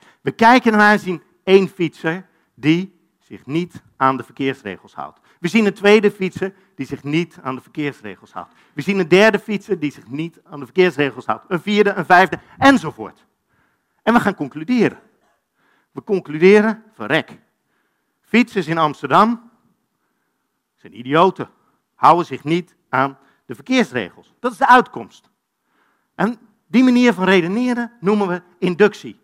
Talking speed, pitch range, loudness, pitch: 150 wpm, 155-210 Hz, -17 LUFS, 185 Hz